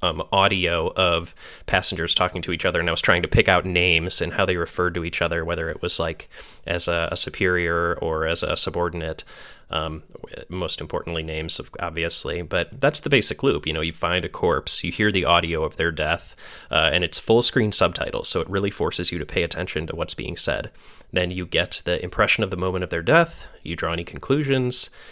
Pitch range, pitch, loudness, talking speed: 85-95 Hz, 85 Hz, -22 LUFS, 220 wpm